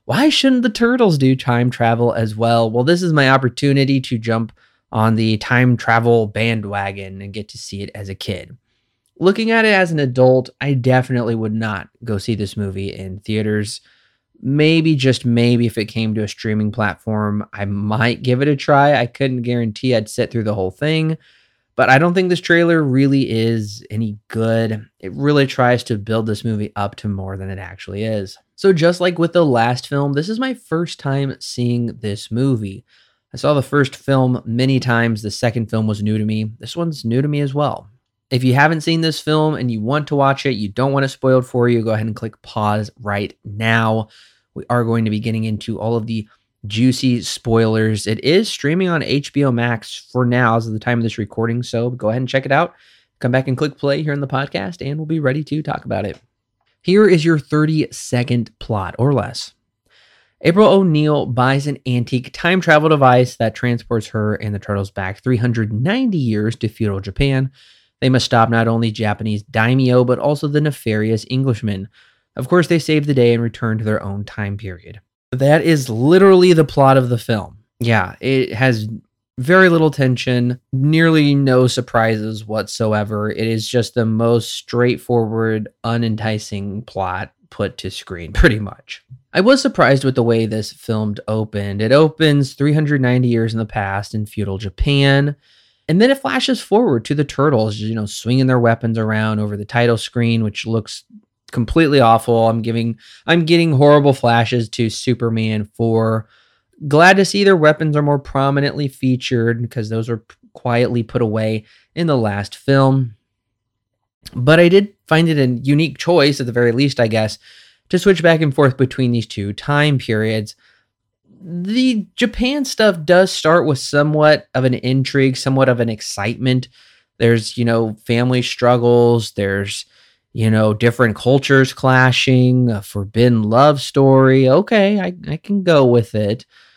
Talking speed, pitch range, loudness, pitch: 185 wpm, 110-140 Hz, -16 LUFS, 120 Hz